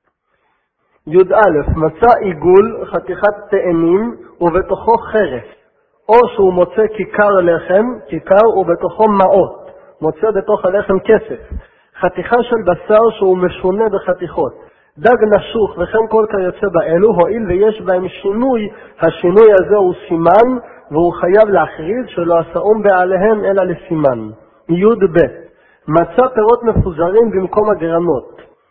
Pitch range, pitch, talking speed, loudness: 175-220 Hz, 195 Hz, 115 wpm, -13 LUFS